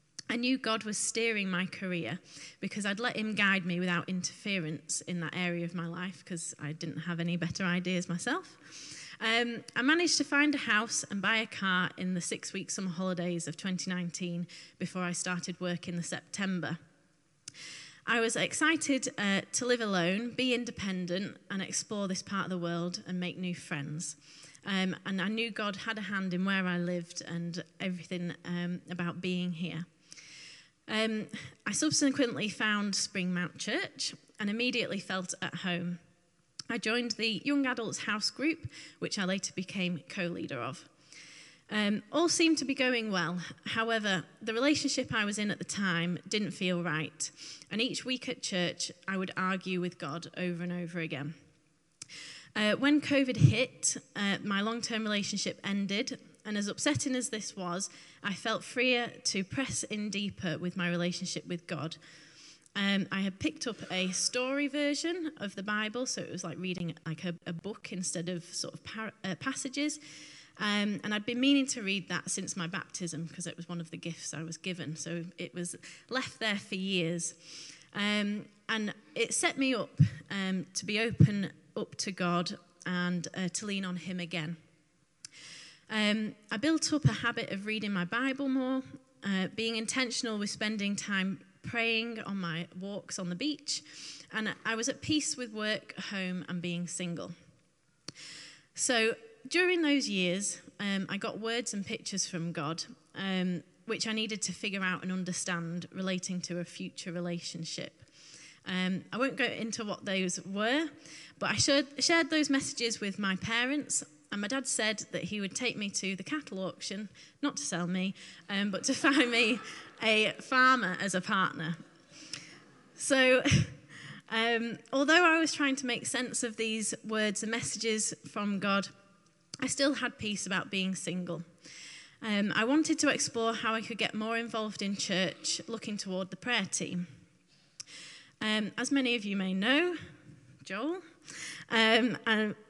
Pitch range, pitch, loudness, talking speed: 175-225 Hz, 195 Hz, -32 LUFS, 170 wpm